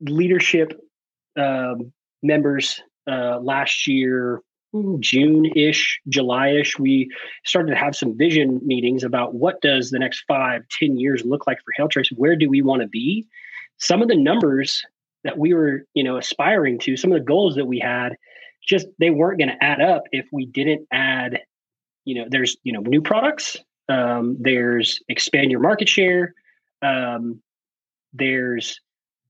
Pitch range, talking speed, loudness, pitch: 130-165 Hz, 165 wpm, -19 LUFS, 140 Hz